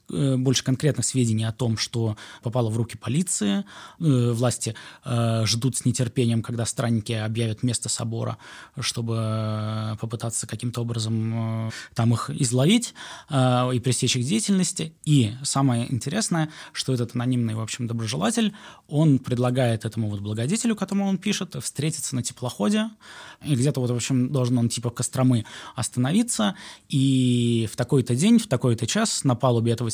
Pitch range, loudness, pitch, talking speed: 115-145 Hz, -24 LUFS, 125 Hz, 150 wpm